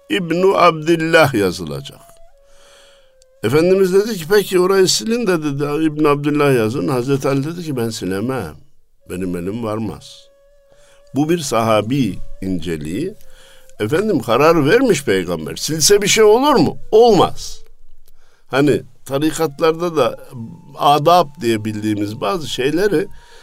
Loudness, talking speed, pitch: -16 LUFS, 115 wpm, 150 Hz